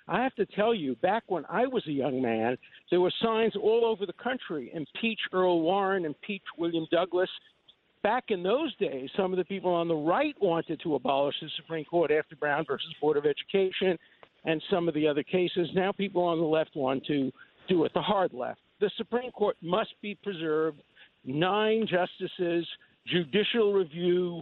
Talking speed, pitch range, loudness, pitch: 185 wpm, 160-205 Hz, -29 LUFS, 180 Hz